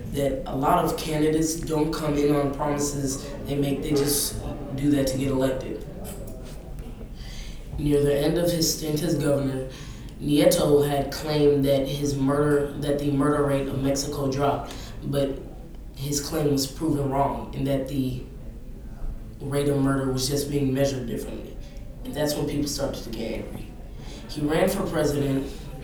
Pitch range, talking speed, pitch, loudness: 135-145 Hz, 160 wpm, 140 Hz, -25 LUFS